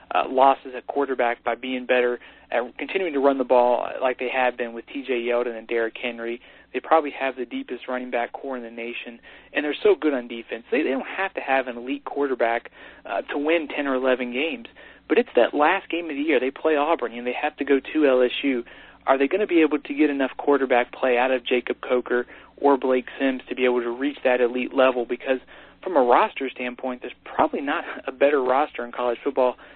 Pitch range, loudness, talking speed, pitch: 125-140 Hz, -23 LUFS, 230 wpm, 130 Hz